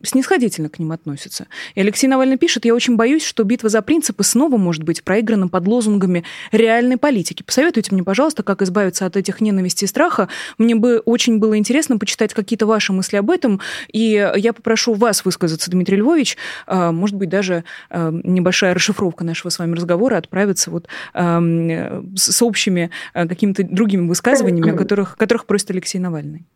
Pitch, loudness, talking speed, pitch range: 200 Hz, -16 LUFS, 165 wpm, 180-230 Hz